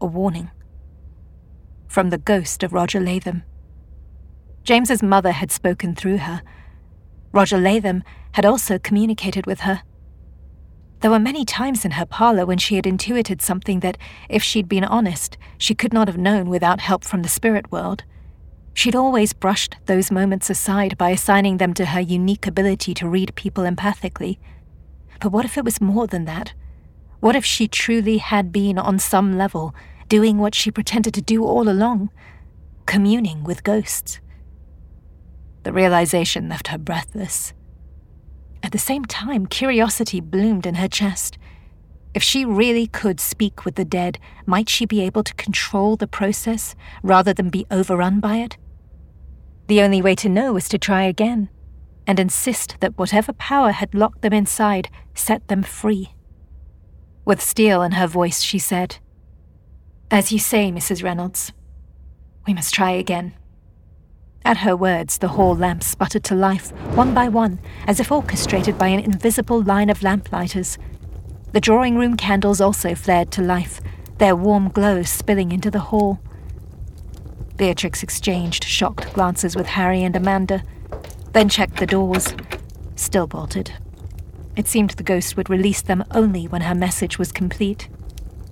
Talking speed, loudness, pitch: 155 wpm, -19 LUFS, 190 Hz